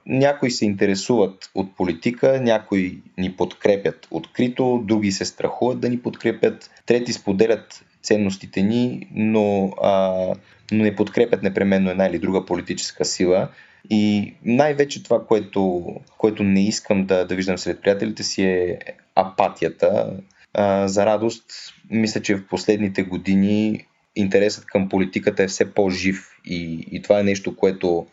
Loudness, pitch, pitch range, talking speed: -21 LUFS, 100 Hz, 95-110 Hz, 140 wpm